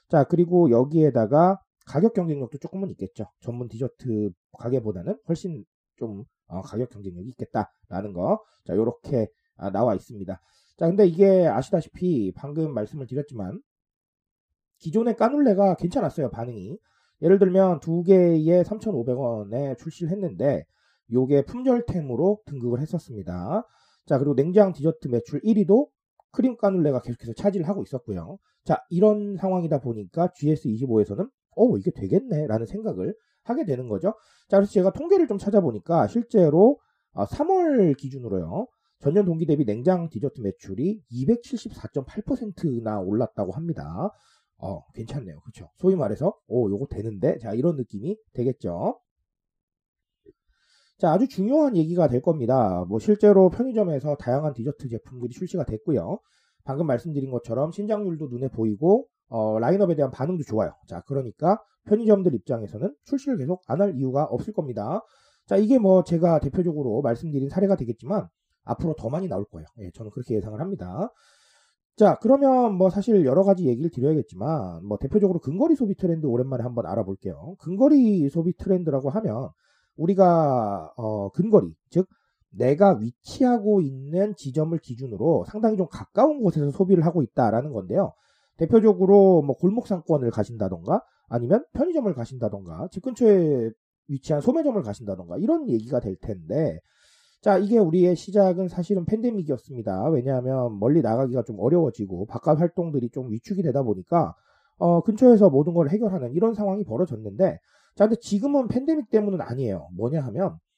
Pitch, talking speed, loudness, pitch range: 160 Hz, 350 characters per minute, -23 LUFS, 120-200 Hz